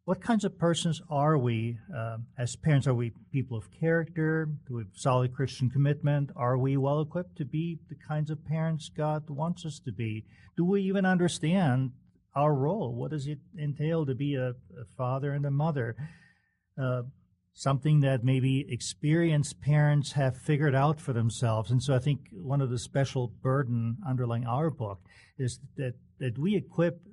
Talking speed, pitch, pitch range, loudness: 180 wpm, 140 Hz, 125-155 Hz, -30 LUFS